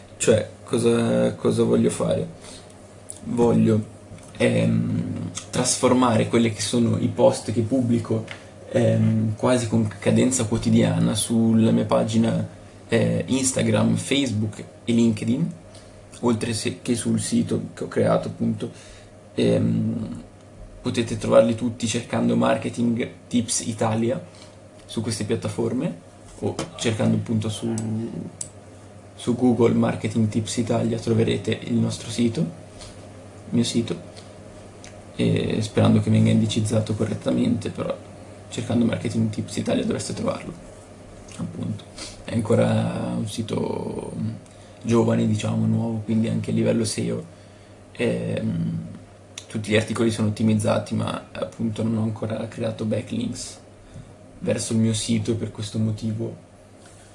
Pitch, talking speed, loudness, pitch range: 110 Hz, 115 wpm, -23 LUFS, 105-115 Hz